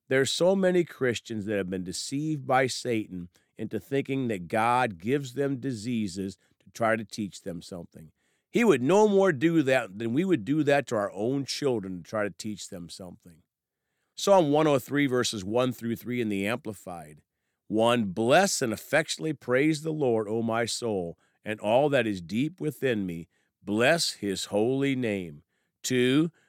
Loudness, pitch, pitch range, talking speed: -27 LUFS, 115 Hz, 100-140 Hz, 170 wpm